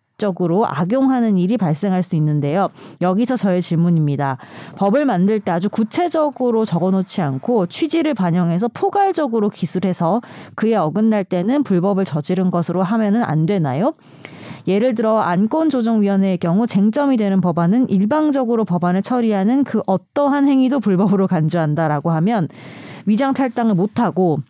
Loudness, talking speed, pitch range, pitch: -17 LUFS, 355 characters per minute, 180-235 Hz, 200 Hz